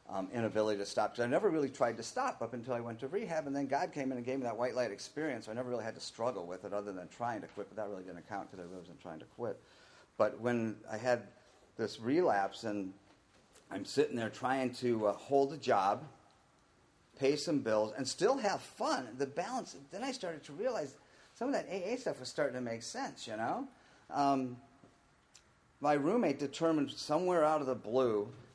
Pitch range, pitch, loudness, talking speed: 105-140 Hz, 125 Hz, -36 LUFS, 220 wpm